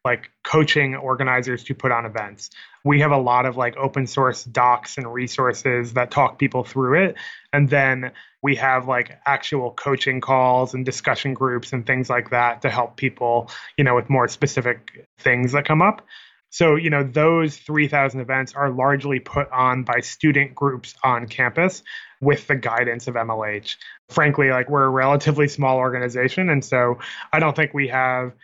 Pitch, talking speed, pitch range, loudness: 130 Hz, 175 wpm, 125-145 Hz, -20 LUFS